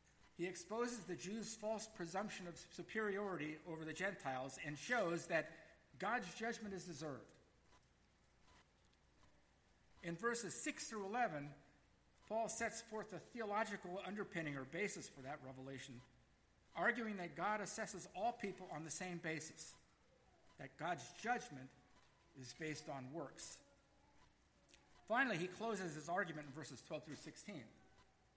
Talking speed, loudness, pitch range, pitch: 130 wpm, -46 LUFS, 150-210 Hz, 175 Hz